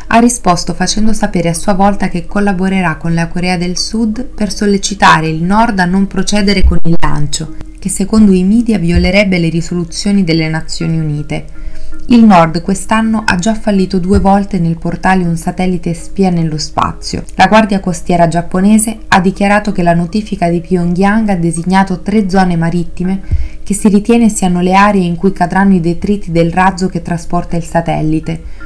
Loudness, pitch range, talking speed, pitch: -11 LUFS, 170-200 Hz, 170 wpm, 185 Hz